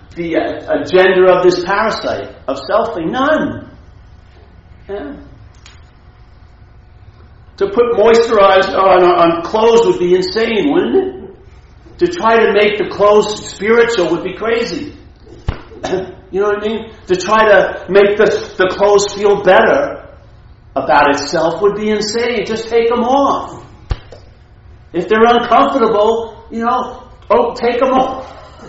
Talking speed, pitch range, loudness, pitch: 130 wpm, 170-230 Hz, -13 LUFS, 205 Hz